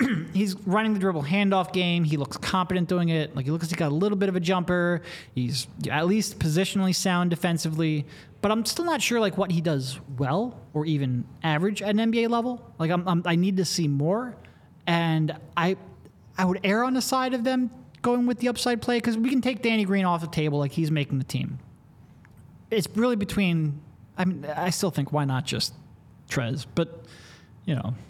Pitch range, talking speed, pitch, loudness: 155-210 Hz, 210 wpm, 180 Hz, -26 LUFS